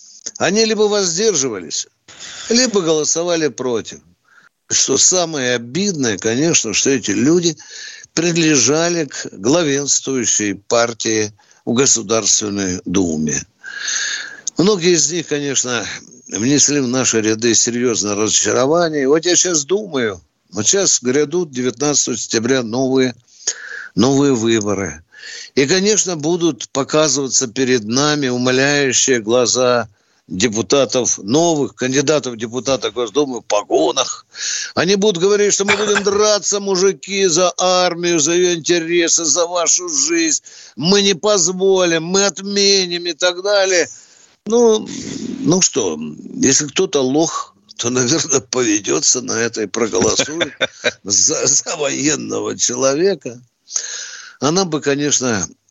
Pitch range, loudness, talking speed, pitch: 125-190 Hz, -15 LUFS, 110 wpm, 150 Hz